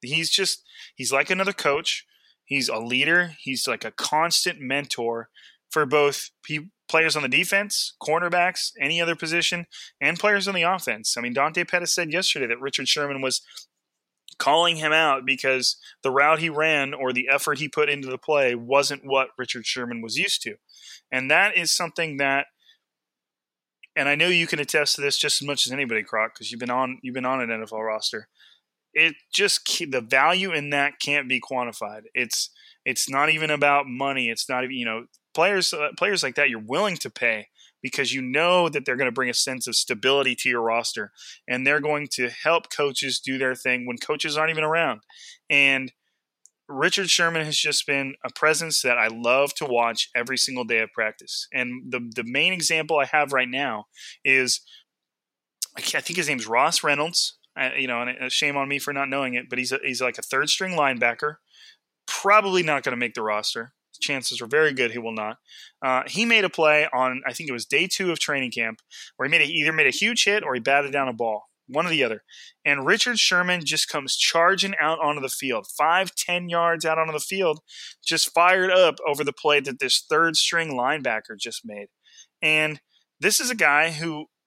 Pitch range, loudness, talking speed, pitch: 130-160 Hz, -22 LUFS, 205 wpm, 140 Hz